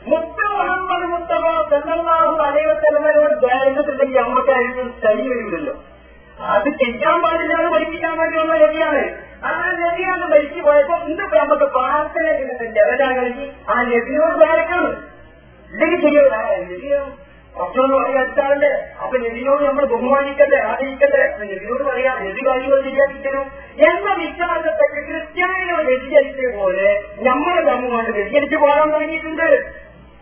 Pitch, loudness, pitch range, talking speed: 290 Hz, -17 LUFS, 265-320 Hz, 105 wpm